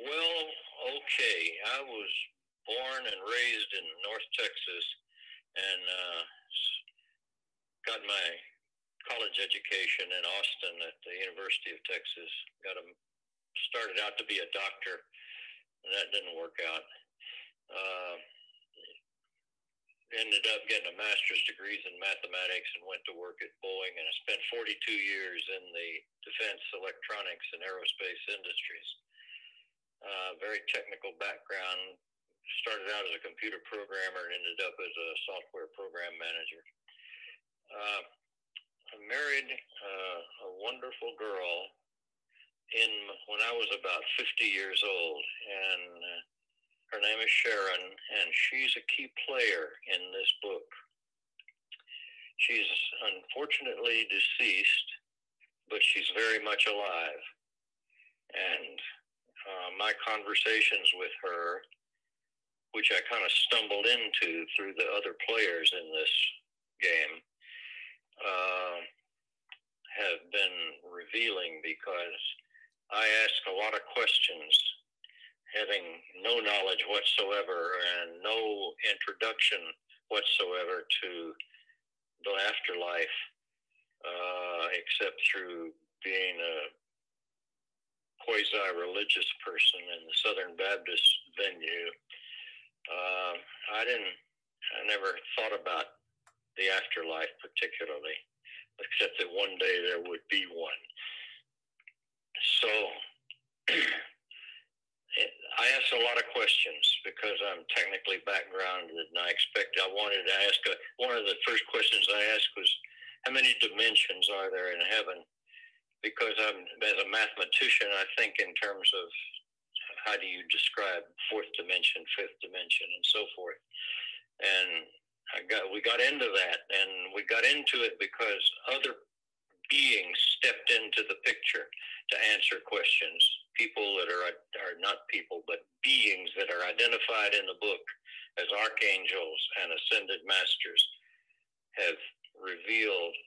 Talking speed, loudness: 120 wpm, -30 LUFS